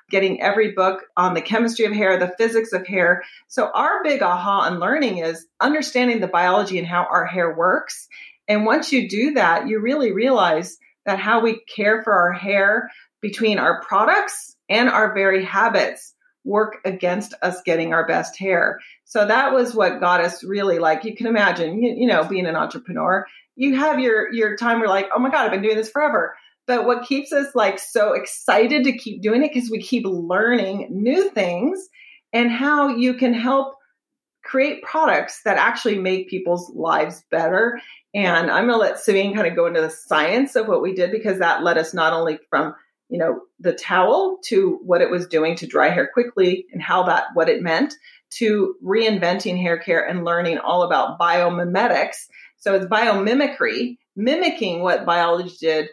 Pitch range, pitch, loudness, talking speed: 180-255 Hz, 215 Hz, -19 LUFS, 190 wpm